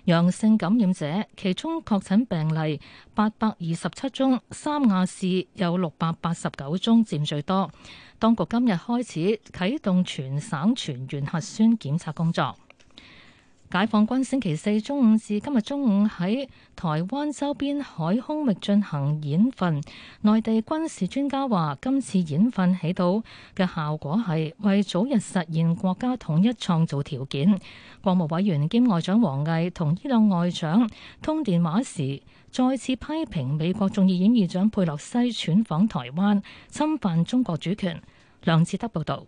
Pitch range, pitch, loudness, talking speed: 165-230 Hz, 195 Hz, -24 LUFS, 230 characters per minute